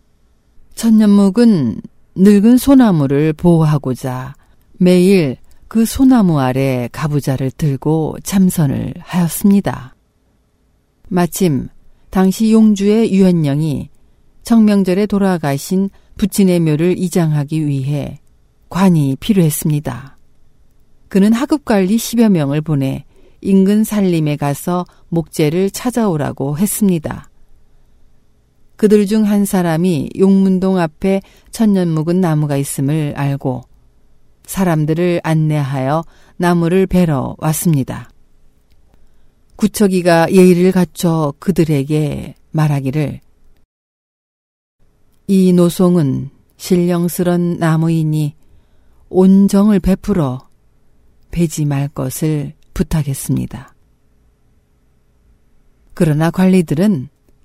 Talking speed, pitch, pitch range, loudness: 210 characters per minute, 170 Hz, 140-195 Hz, -14 LUFS